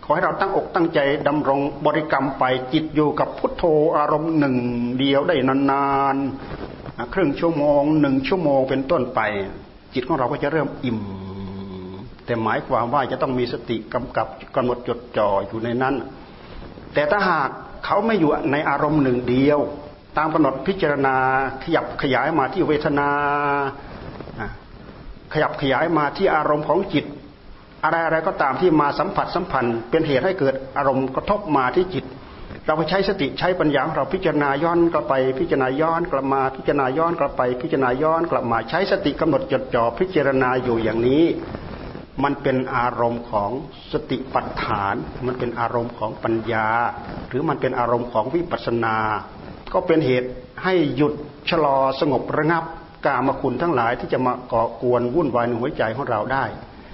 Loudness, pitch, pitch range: -21 LUFS, 135 Hz, 125-150 Hz